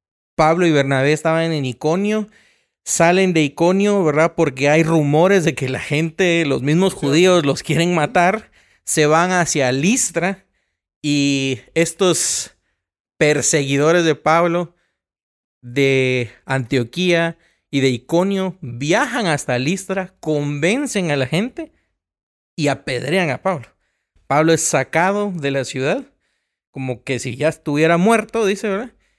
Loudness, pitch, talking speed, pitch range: -17 LUFS, 160 Hz, 125 wpm, 140-180 Hz